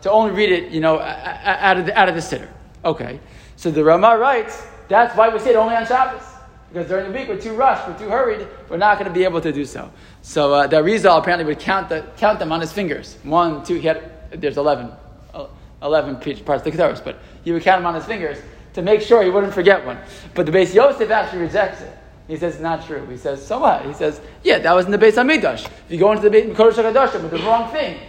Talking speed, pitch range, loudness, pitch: 255 wpm, 165-225 Hz, -17 LUFS, 190 Hz